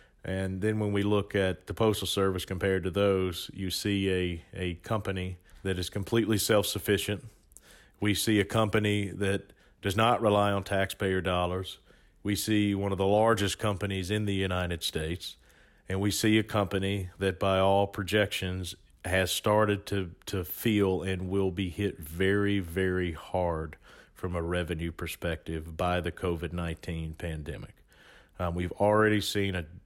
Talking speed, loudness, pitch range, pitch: 160 wpm, -29 LUFS, 90-100 Hz, 95 Hz